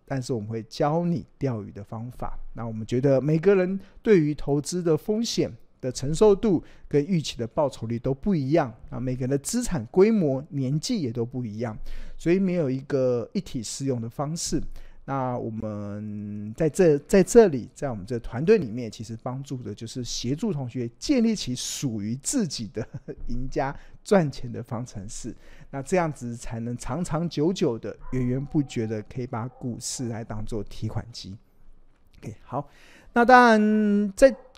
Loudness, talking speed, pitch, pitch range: -25 LUFS, 260 characters per minute, 135 Hz, 115-165 Hz